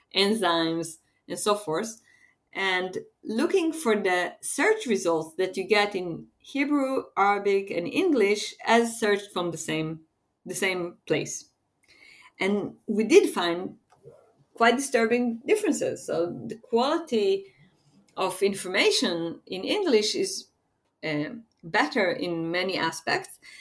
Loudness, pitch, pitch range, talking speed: -26 LUFS, 200 Hz, 175-240 Hz, 115 wpm